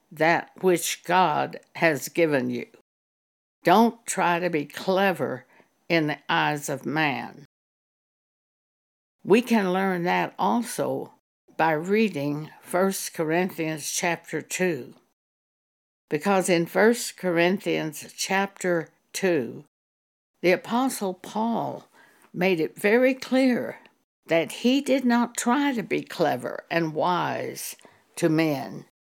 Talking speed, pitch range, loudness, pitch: 105 wpm, 155-205 Hz, -25 LUFS, 175 Hz